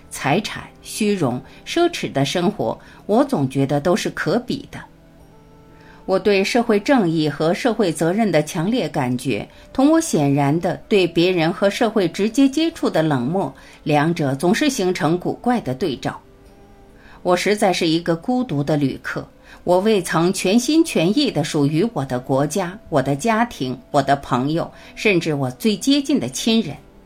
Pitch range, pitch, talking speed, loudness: 145-215 Hz, 175 Hz, 235 characters per minute, -19 LUFS